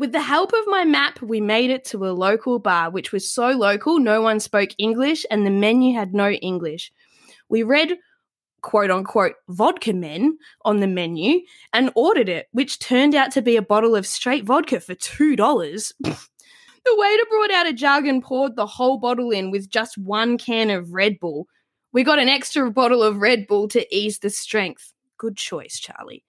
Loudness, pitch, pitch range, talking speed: -19 LUFS, 235 Hz, 205-275 Hz, 195 wpm